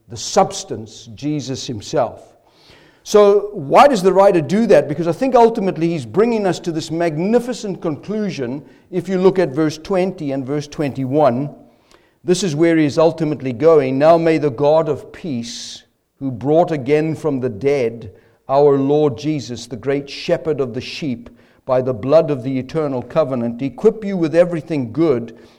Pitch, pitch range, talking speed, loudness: 150 Hz, 130-175 Hz, 165 wpm, -17 LUFS